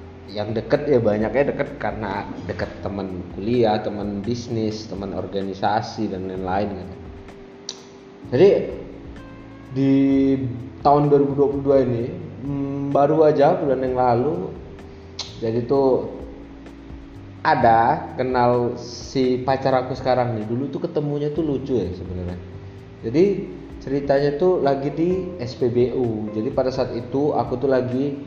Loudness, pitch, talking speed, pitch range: -21 LUFS, 120 Hz, 115 wpm, 100-135 Hz